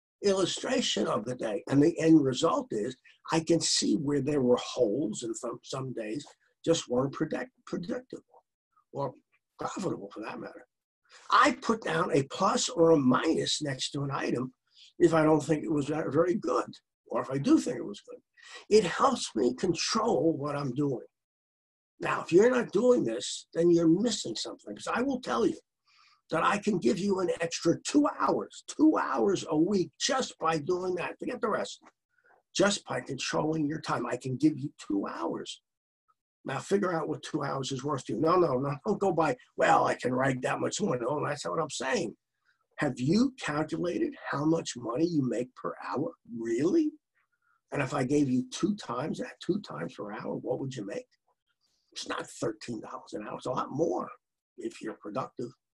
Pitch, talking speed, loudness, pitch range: 165 Hz, 190 wpm, -29 LUFS, 150-245 Hz